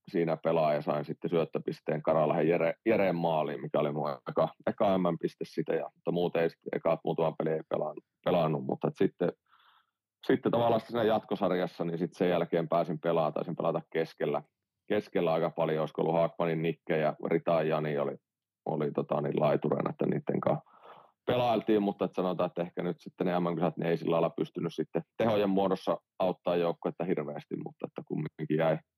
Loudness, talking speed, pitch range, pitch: -31 LUFS, 170 wpm, 80-90 Hz, 85 Hz